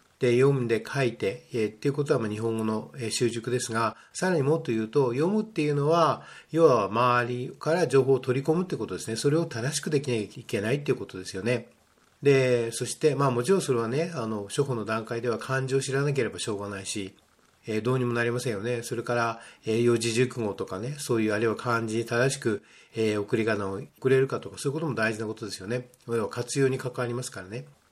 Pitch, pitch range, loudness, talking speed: 120 Hz, 110-135 Hz, -27 LUFS, 460 characters per minute